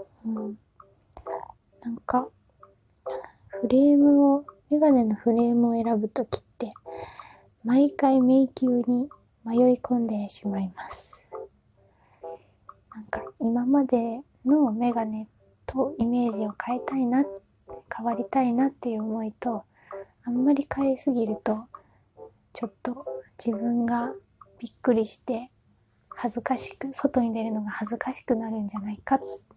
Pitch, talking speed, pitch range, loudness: 240 Hz, 250 characters per minute, 220-265 Hz, -26 LUFS